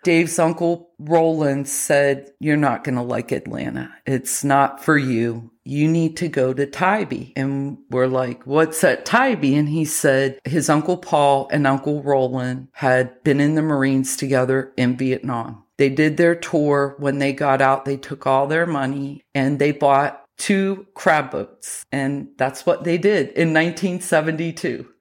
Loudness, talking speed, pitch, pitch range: -20 LUFS, 165 wpm, 140 Hz, 135-160 Hz